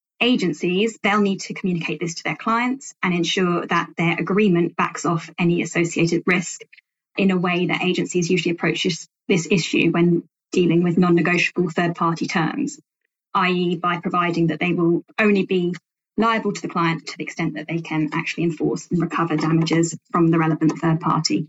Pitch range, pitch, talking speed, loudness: 165-185 Hz, 170 Hz, 180 wpm, -21 LUFS